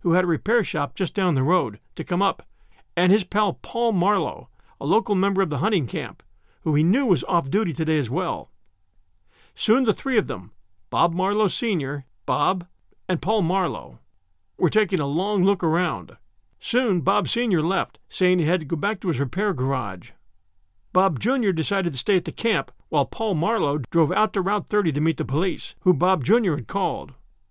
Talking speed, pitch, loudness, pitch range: 195 wpm, 180 Hz, -23 LUFS, 145-200 Hz